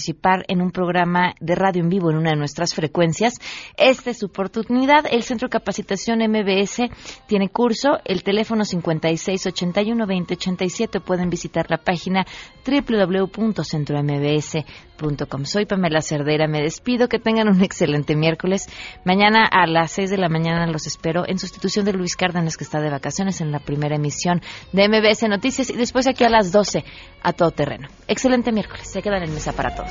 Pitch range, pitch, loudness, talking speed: 165-210 Hz, 185 Hz, -20 LUFS, 175 wpm